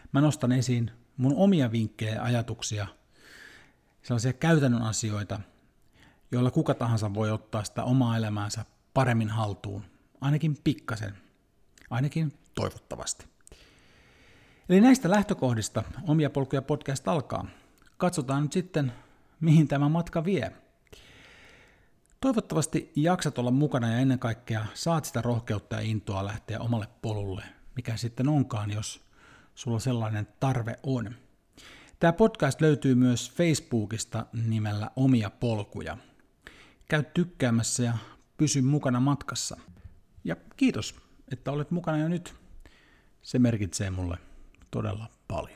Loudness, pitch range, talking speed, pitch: -28 LUFS, 110-145 Hz, 115 wpm, 125 Hz